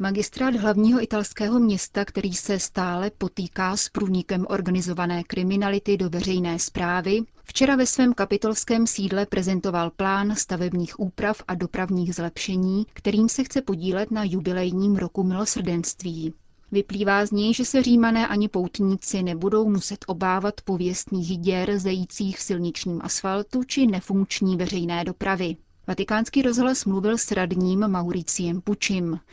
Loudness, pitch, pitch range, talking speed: -24 LUFS, 195 Hz, 185-210 Hz, 130 wpm